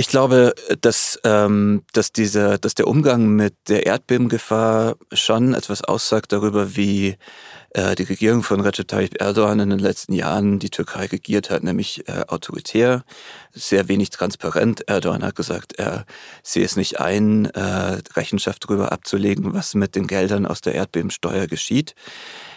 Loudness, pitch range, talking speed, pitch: -19 LUFS, 100-110 Hz, 145 wpm, 105 Hz